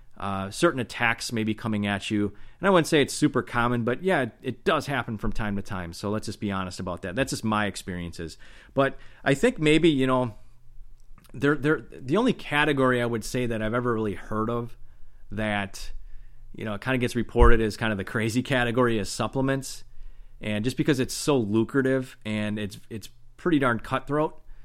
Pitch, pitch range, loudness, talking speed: 120 Hz, 105-135 Hz, -26 LUFS, 200 wpm